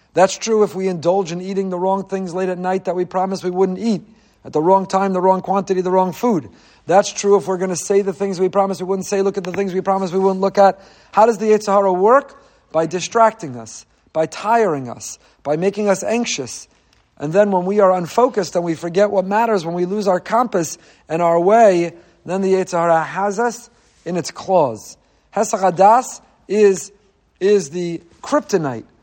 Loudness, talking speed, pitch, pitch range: -17 LUFS, 205 wpm, 190 Hz, 180-205 Hz